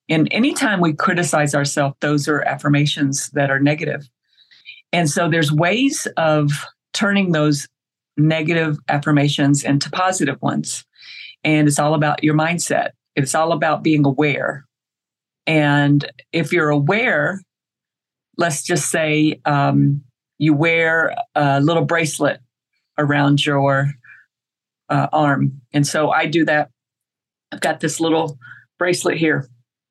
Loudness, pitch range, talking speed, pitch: -18 LUFS, 140-165 Hz, 125 wpm, 150 Hz